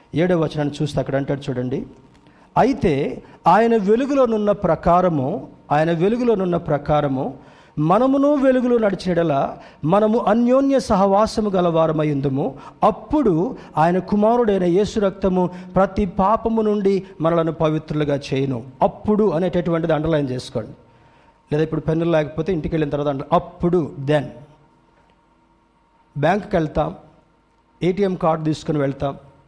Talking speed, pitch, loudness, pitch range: 105 wpm, 165 Hz, -19 LUFS, 150-195 Hz